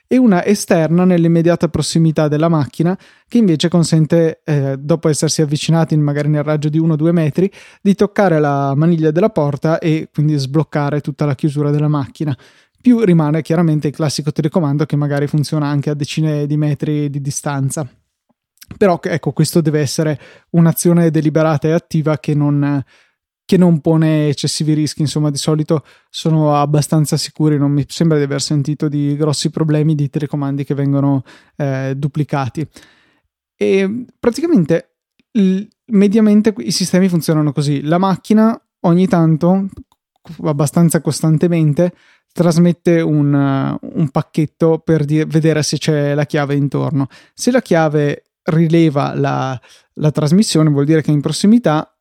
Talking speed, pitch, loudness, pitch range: 145 wpm, 155 Hz, -15 LUFS, 150-170 Hz